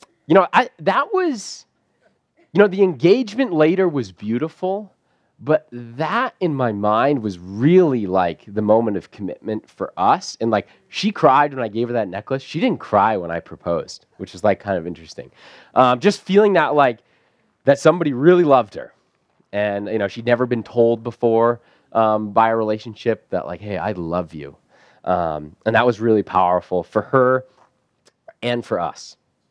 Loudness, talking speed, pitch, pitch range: -19 LUFS, 175 wpm, 120 Hz, 105-160 Hz